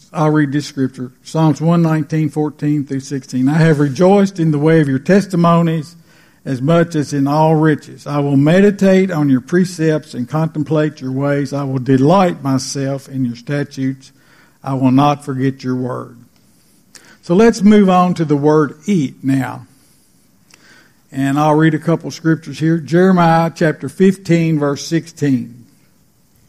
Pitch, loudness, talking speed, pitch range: 150 Hz, -15 LUFS, 160 wpm, 135-165 Hz